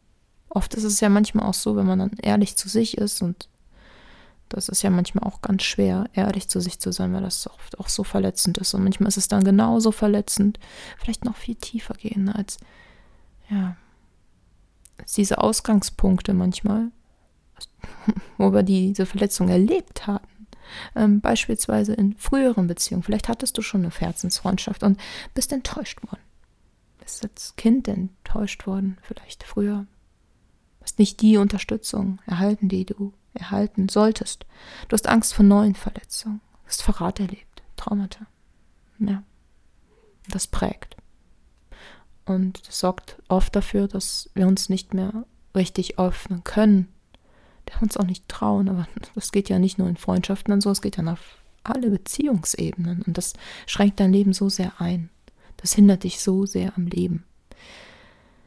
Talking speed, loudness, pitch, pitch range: 155 wpm, -22 LUFS, 200 Hz, 185-210 Hz